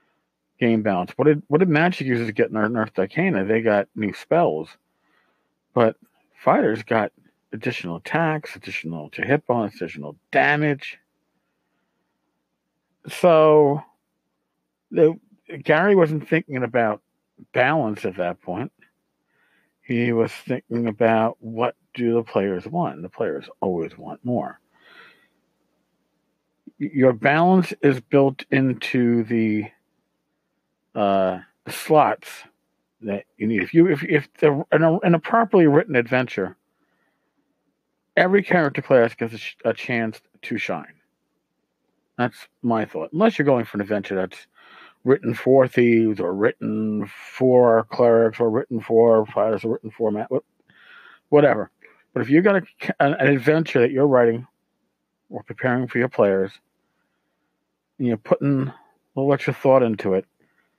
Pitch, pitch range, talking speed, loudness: 120 Hz, 105-145 Hz, 135 wpm, -21 LUFS